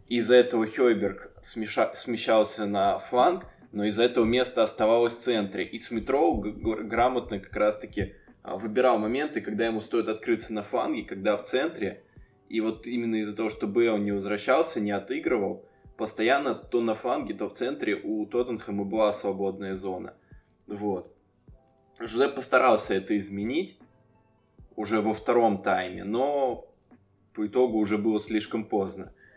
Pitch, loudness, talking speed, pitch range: 110 Hz, -27 LUFS, 145 wpm, 105-115 Hz